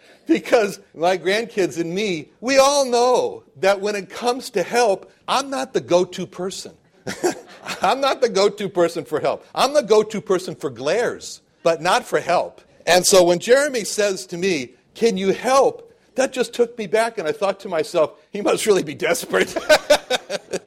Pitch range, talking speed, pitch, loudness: 180-250 Hz, 185 wpm, 205 Hz, -20 LUFS